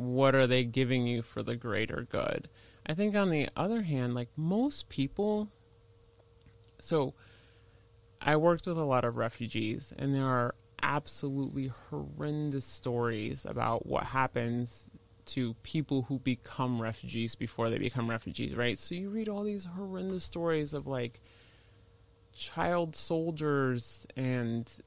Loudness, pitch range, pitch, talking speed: -33 LUFS, 115-150 Hz, 125 Hz, 140 wpm